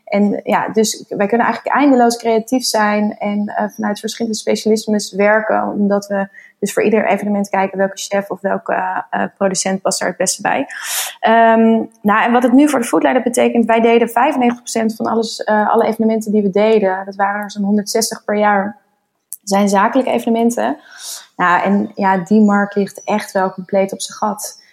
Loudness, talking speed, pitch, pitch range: -15 LUFS, 185 wpm, 210 Hz, 200-230 Hz